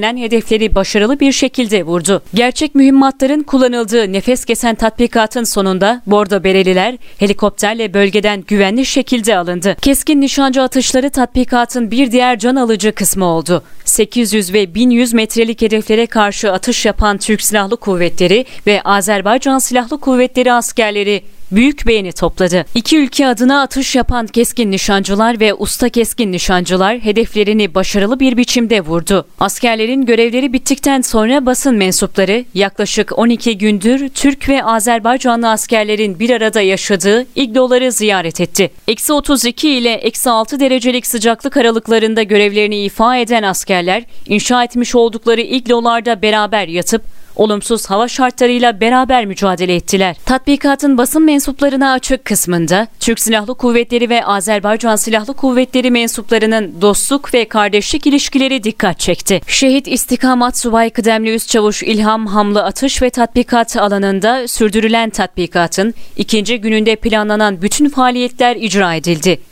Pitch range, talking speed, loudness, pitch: 205-250 Hz, 125 wpm, -12 LUFS, 230 Hz